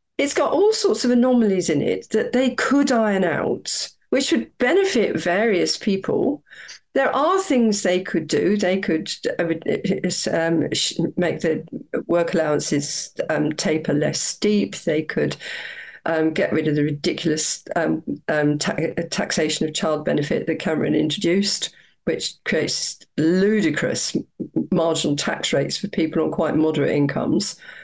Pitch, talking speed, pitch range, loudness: 180 Hz, 140 wpm, 160-220 Hz, -20 LUFS